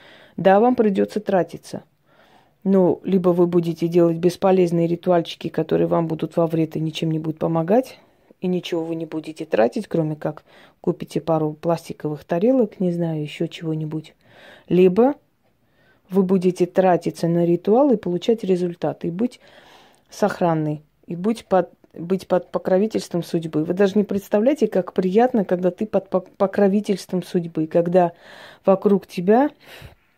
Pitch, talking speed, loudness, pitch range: 180 Hz, 140 wpm, -21 LUFS, 165-200 Hz